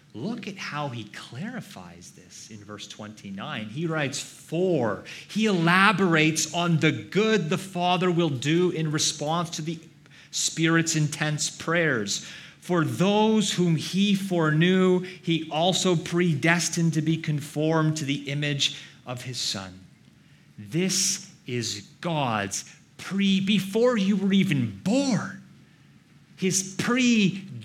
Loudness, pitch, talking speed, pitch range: -24 LUFS, 165 Hz, 120 wpm, 145-185 Hz